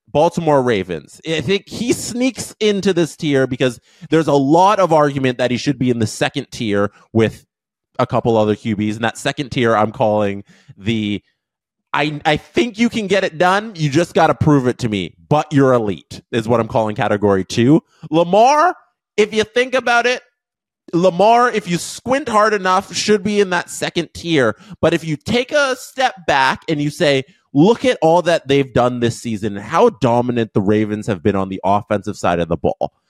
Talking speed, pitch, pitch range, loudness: 200 wpm, 145 Hz, 115-190 Hz, -16 LUFS